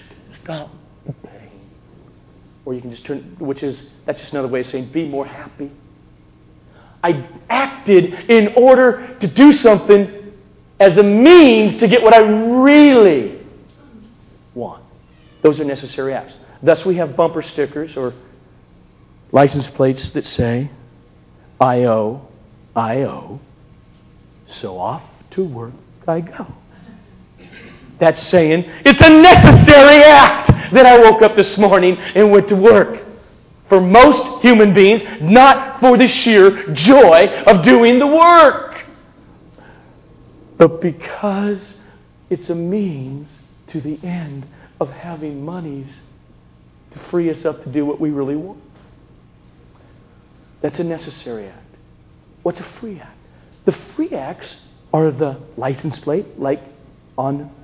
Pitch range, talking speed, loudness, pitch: 130-205 Hz, 130 wpm, -10 LUFS, 155 Hz